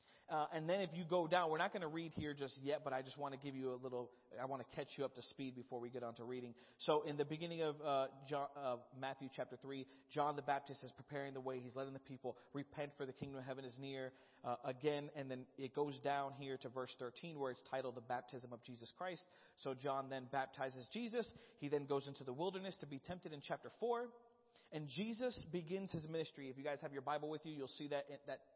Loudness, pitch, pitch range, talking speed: -46 LUFS, 140 Hz, 130-155 Hz, 255 wpm